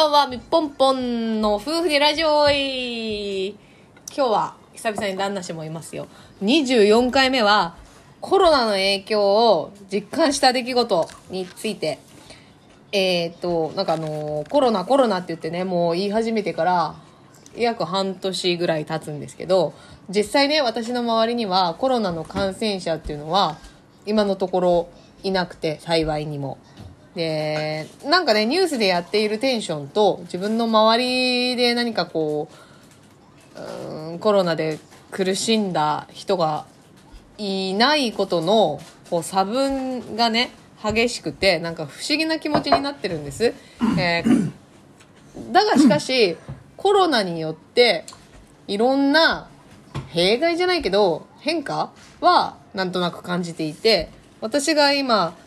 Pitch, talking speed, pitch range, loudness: 205 Hz, 270 characters per minute, 175-250 Hz, -21 LUFS